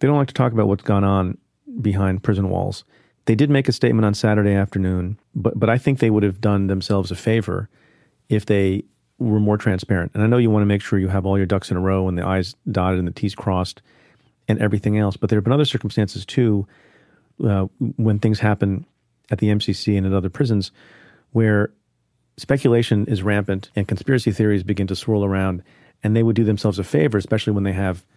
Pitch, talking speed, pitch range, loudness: 105 Hz, 220 wpm, 95-115 Hz, -20 LUFS